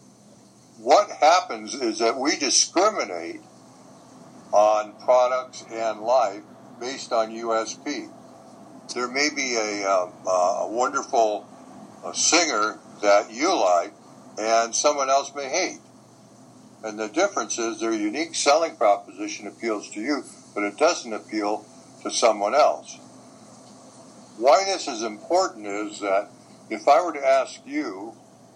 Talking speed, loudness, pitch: 125 wpm, -23 LUFS, 125 Hz